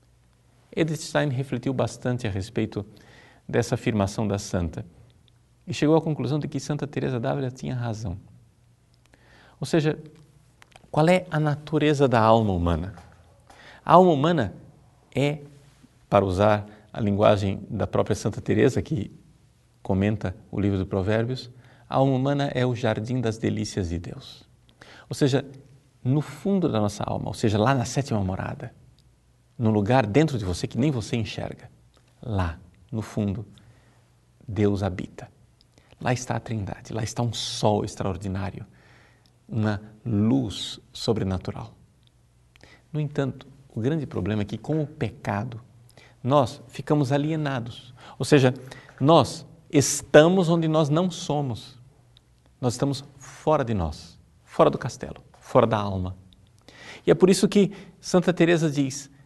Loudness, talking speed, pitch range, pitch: -24 LUFS, 140 wpm, 105-140 Hz, 125 Hz